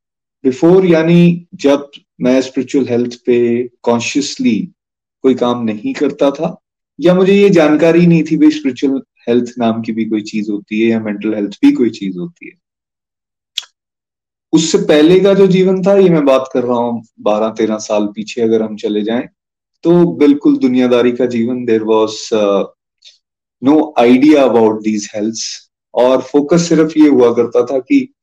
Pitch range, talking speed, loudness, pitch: 115-160 Hz, 160 wpm, -12 LUFS, 130 Hz